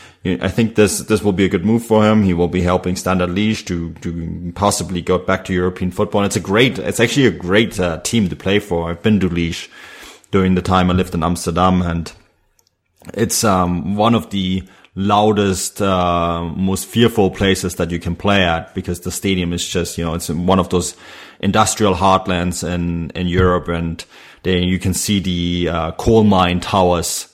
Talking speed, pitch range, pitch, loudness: 200 wpm, 90-100 Hz, 90 Hz, -17 LUFS